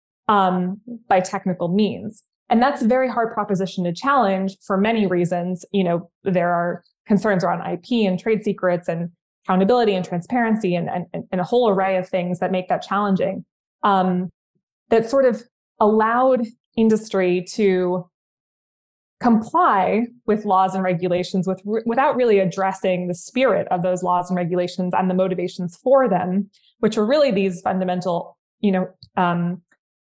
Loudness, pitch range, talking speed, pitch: -20 LUFS, 180-220 Hz, 155 wpm, 190 Hz